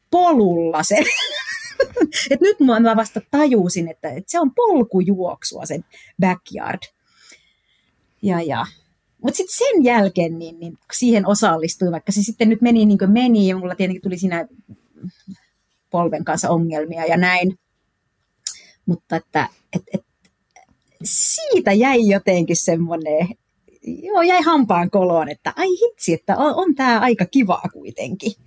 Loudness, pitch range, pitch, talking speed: -18 LUFS, 175-250 Hz, 200 Hz, 135 wpm